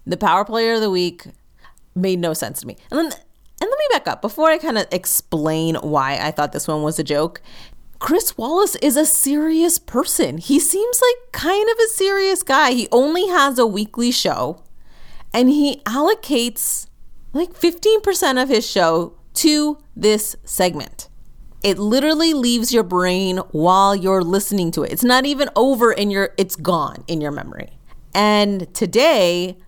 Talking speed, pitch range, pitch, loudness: 170 wpm, 180-300 Hz, 225 Hz, -17 LUFS